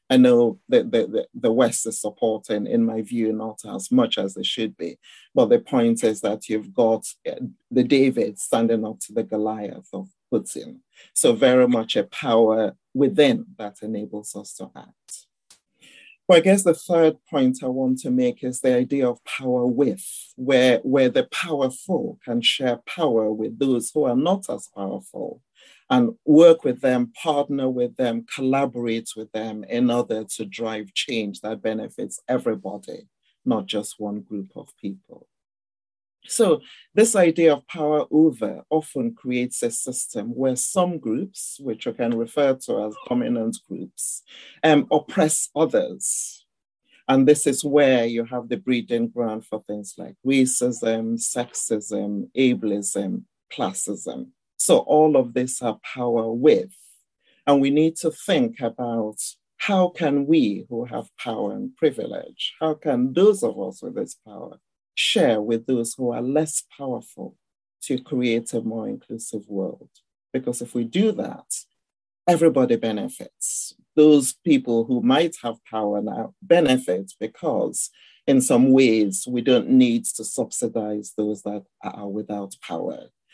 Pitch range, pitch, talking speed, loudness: 110-165 Hz, 125 Hz, 150 wpm, -22 LUFS